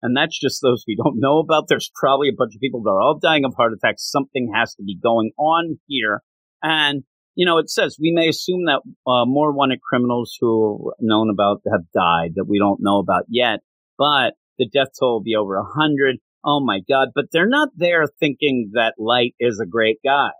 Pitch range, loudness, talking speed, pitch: 110-150 Hz, -19 LUFS, 225 wpm, 125 Hz